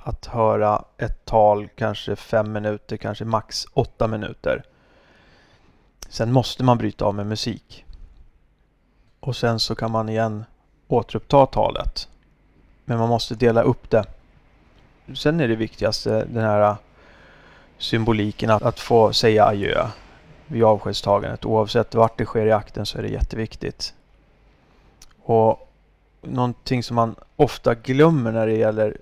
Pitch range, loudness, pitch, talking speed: 105-120 Hz, -21 LUFS, 110 Hz, 135 wpm